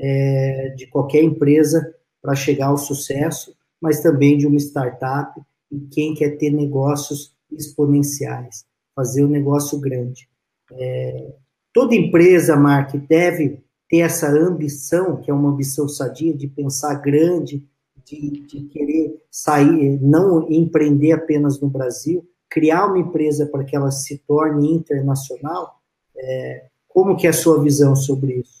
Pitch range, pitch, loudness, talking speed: 140-155 Hz, 145 Hz, -17 LUFS, 140 wpm